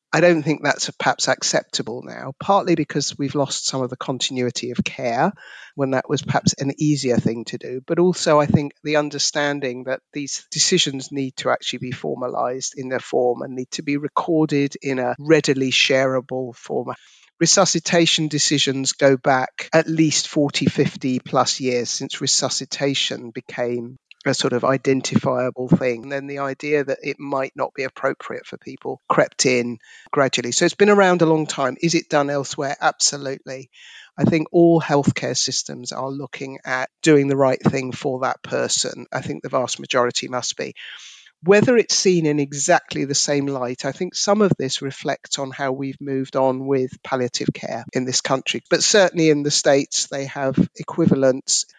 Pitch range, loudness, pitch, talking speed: 130-155 Hz, -20 LUFS, 140 Hz, 175 wpm